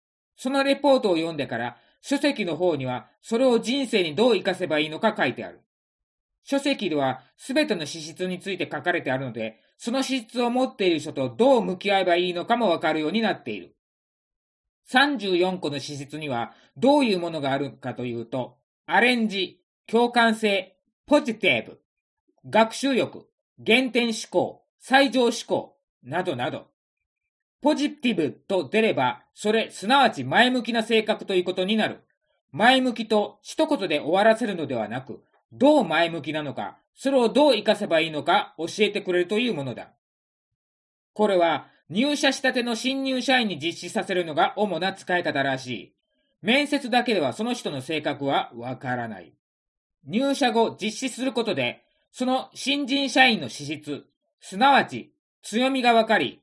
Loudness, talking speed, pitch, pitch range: -23 LUFS, 315 characters per minute, 210 Hz, 160-255 Hz